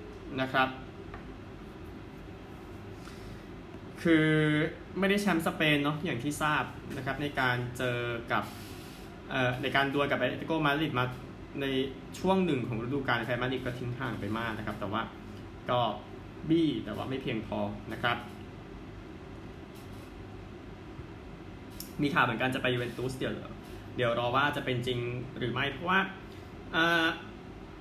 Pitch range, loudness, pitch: 115-145 Hz, -31 LUFS, 125 Hz